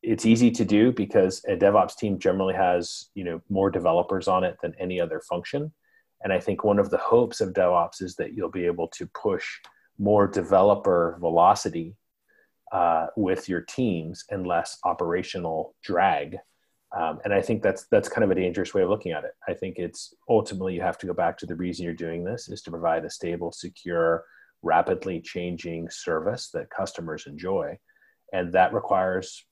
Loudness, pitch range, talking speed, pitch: -25 LUFS, 85-110 Hz, 185 wpm, 95 Hz